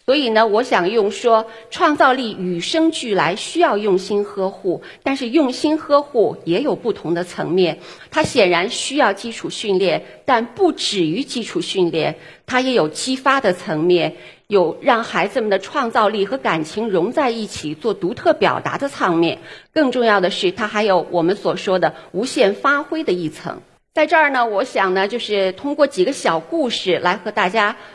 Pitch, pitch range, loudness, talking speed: 215 Hz, 180-275 Hz, -18 LUFS, 260 characters per minute